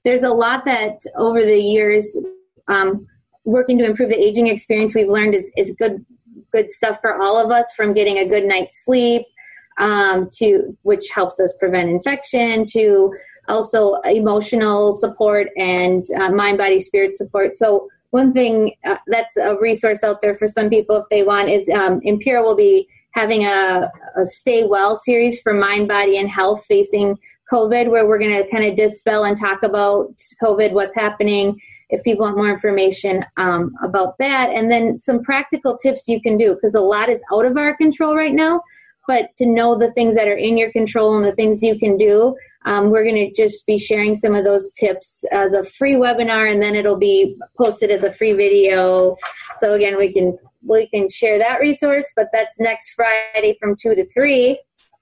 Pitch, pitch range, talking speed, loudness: 215 Hz, 205-240 Hz, 195 wpm, -16 LUFS